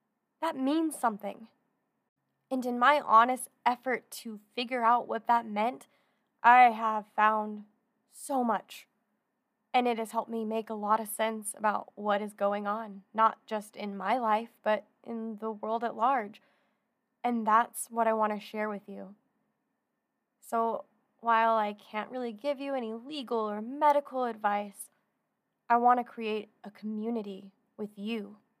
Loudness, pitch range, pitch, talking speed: -30 LUFS, 215-245 Hz, 225 Hz, 155 wpm